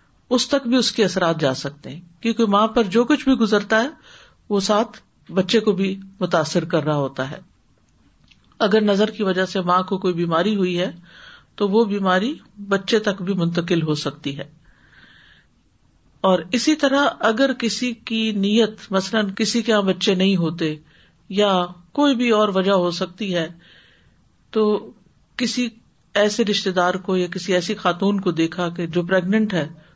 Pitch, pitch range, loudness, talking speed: 195 Hz, 175-220 Hz, -20 LUFS, 170 wpm